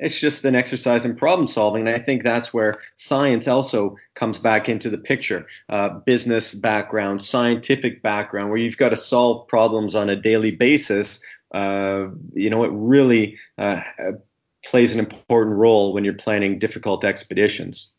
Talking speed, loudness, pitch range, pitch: 165 wpm, -20 LUFS, 105-120 Hz, 110 Hz